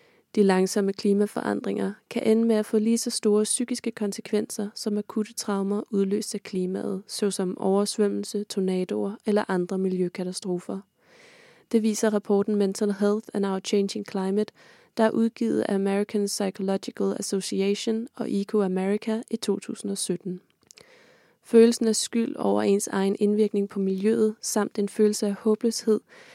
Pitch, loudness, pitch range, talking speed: 210 Hz, -25 LUFS, 195-225 Hz, 135 wpm